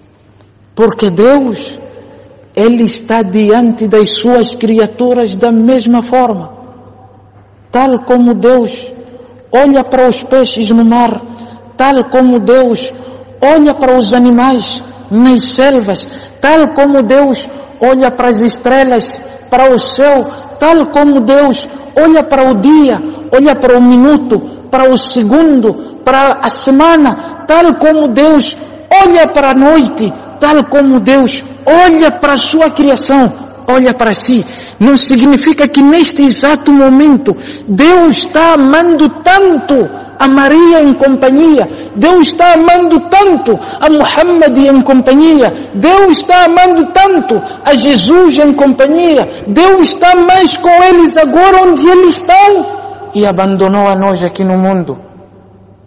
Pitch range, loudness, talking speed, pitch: 245-310 Hz, -7 LUFS, 130 wpm, 270 Hz